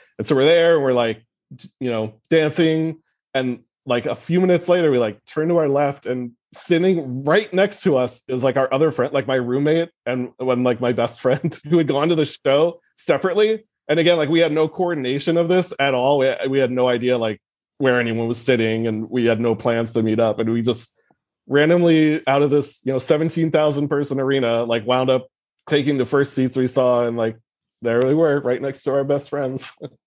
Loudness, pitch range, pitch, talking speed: -19 LUFS, 125-160 Hz, 135 Hz, 220 wpm